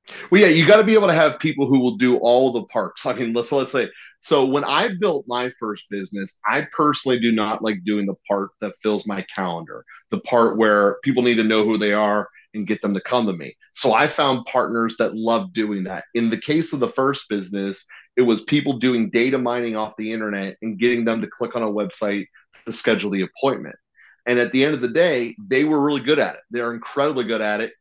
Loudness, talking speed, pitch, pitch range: -20 LUFS, 240 wpm, 115 Hz, 105-125 Hz